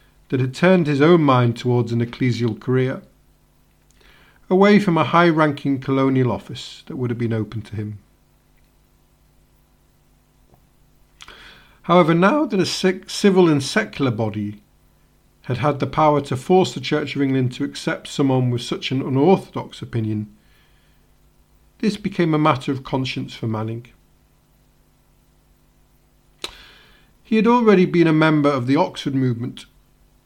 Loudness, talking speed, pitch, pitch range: -19 LUFS, 135 wpm, 135 Hz, 115-170 Hz